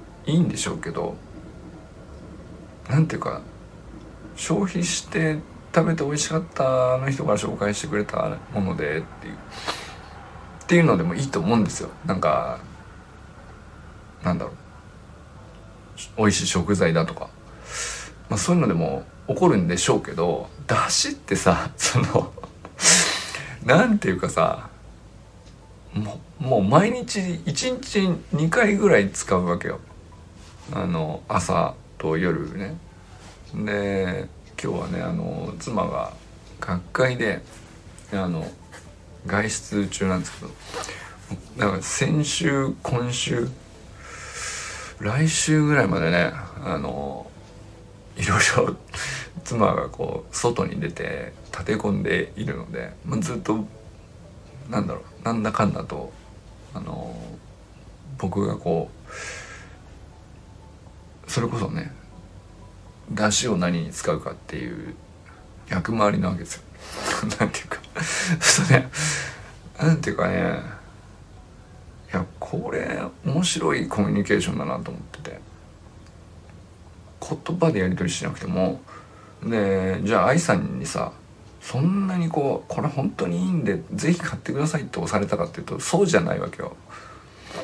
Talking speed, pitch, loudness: 235 characters per minute, 105 Hz, -24 LUFS